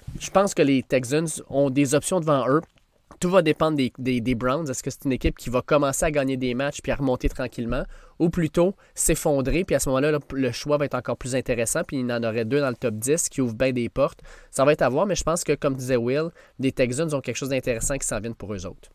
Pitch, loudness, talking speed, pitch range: 135 Hz, -24 LUFS, 270 wpm, 125-150 Hz